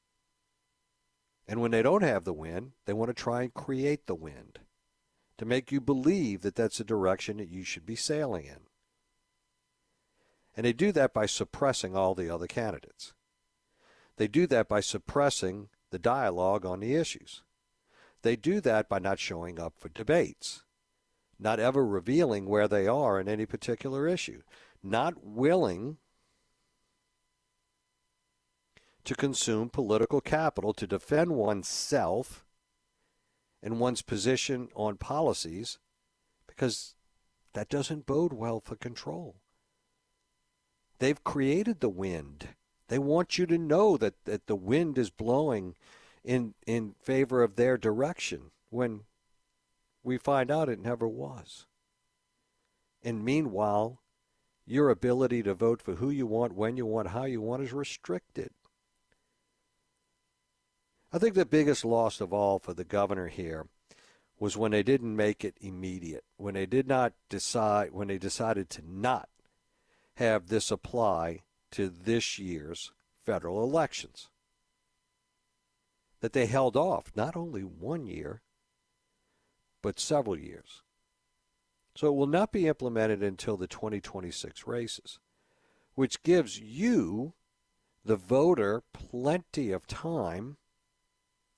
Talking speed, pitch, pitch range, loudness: 130 wpm, 115 Hz, 100-135 Hz, -30 LUFS